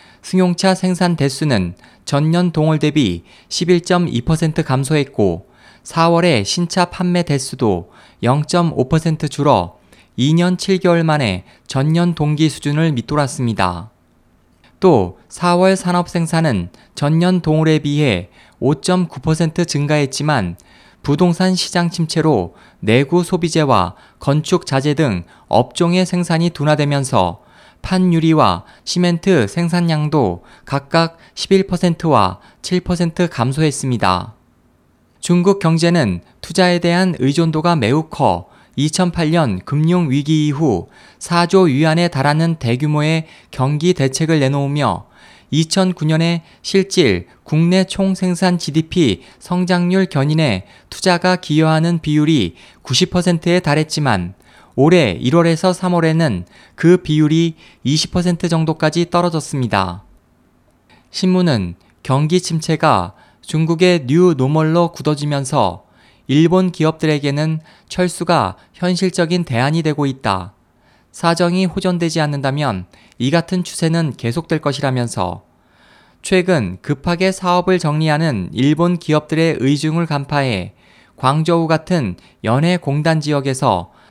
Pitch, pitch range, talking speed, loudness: 155 Hz, 130-175 Hz, 230 characters per minute, -16 LUFS